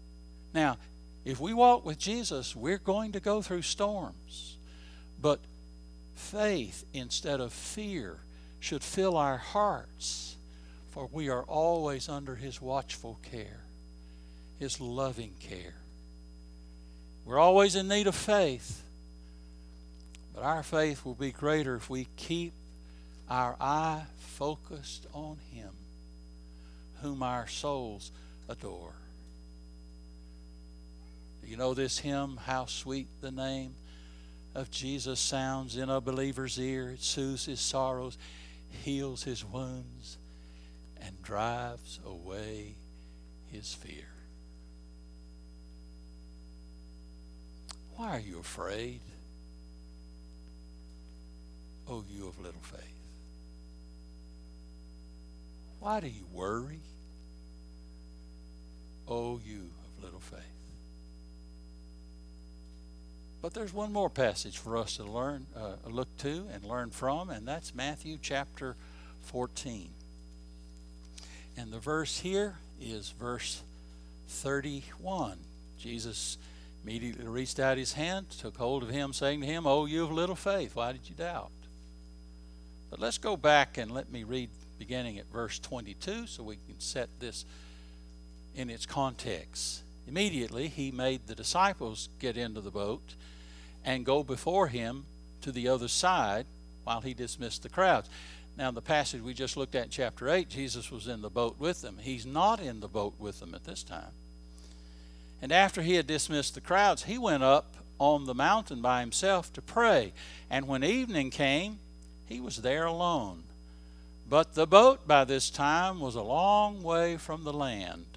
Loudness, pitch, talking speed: -32 LUFS, 100 Hz, 130 wpm